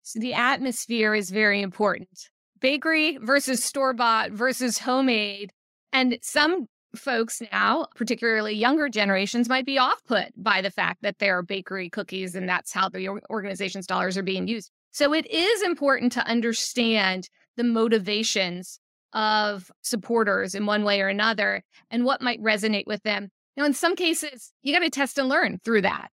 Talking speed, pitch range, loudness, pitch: 165 wpm, 205-260 Hz, -24 LUFS, 225 Hz